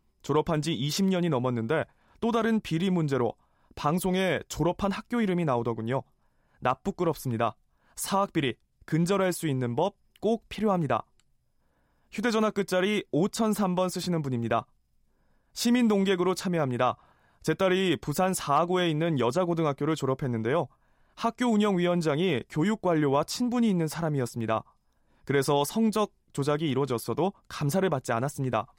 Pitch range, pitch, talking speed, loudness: 135-190 Hz, 165 Hz, 325 characters per minute, -28 LUFS